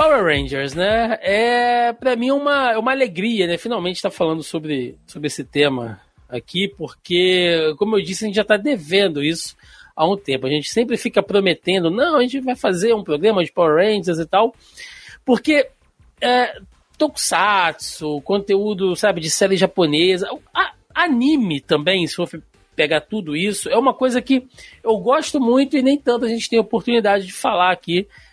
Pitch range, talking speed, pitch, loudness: 165-240 Hz, 175 wpm, 200 Hz, -18 LUFS